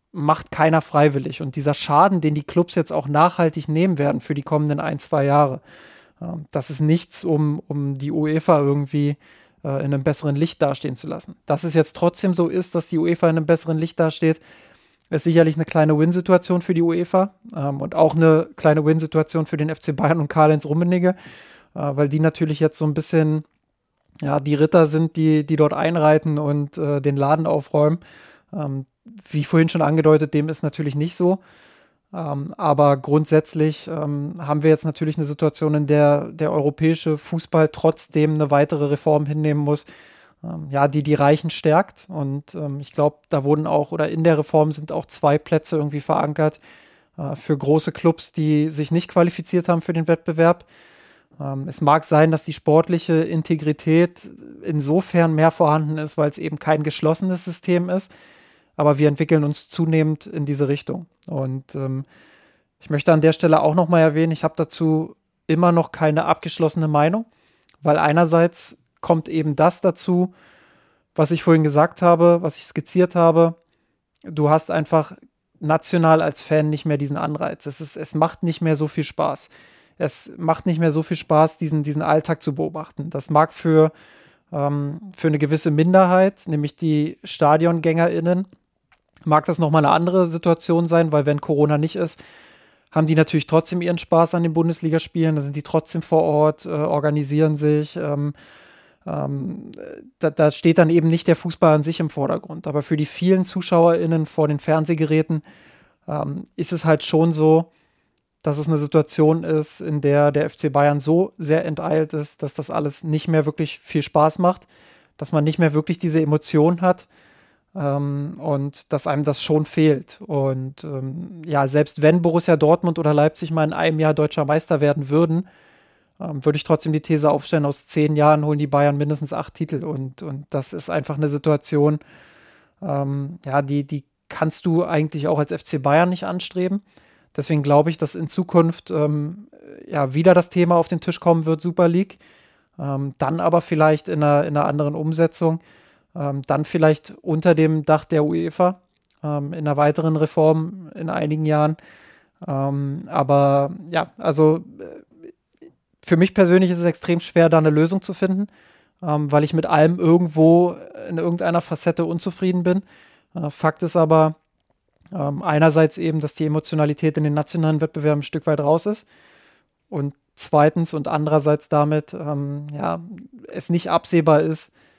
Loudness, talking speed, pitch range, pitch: -19 LUFS, 170 wpm, 150-170 Hz, 155 Hz